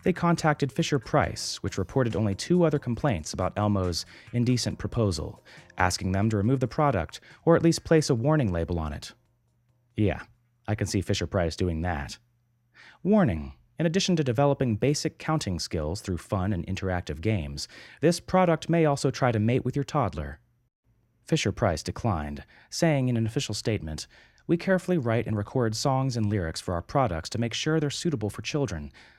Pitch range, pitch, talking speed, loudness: 95-145 Hz, 115 Hz, 175 wpm, -27 LUFS